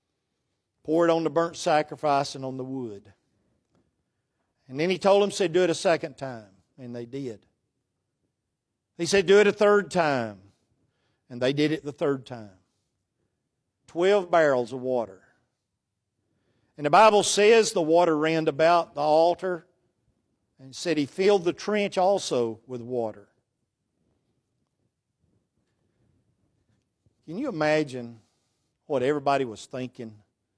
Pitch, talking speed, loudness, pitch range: 130 Hz, 135 wpm, -24 LUFS, 115-165 Hz